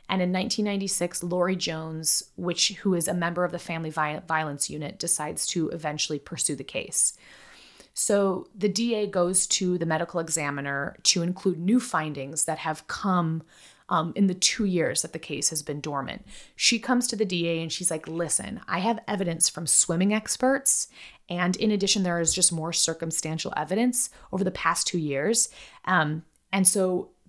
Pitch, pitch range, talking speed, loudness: 175 Hz, 160-195 Hz, 175 wpm, -25 LUFS